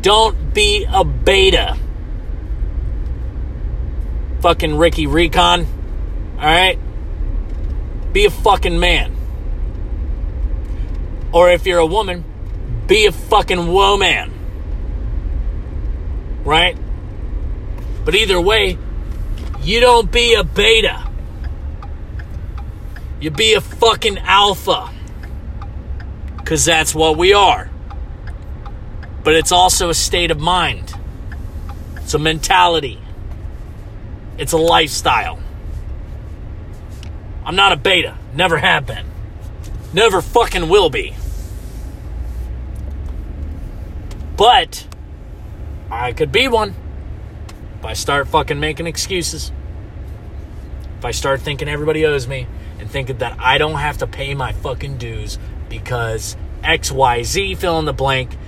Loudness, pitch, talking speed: -15 LUFS, 100 Hz, 100 wpm